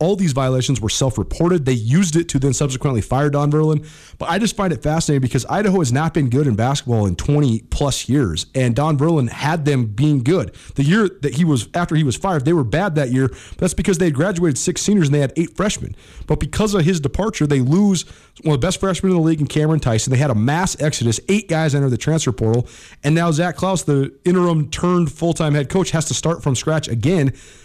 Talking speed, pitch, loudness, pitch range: 240 wpm, 150 Hz, -18 LUFS, 135-175 Hz